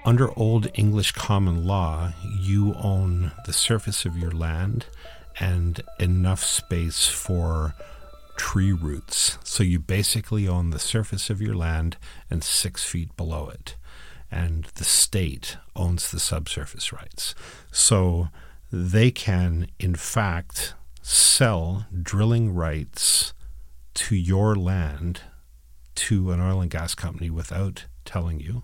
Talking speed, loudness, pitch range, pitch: 125 wpm, -23 LUFS, 80-100 Hz, 90 Hz